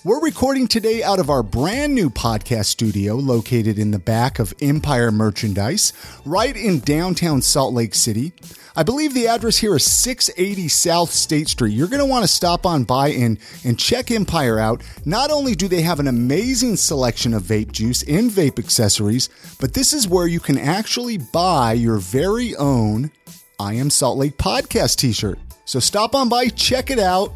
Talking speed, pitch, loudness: 185 wpm, 145 Hz, -18 LUFS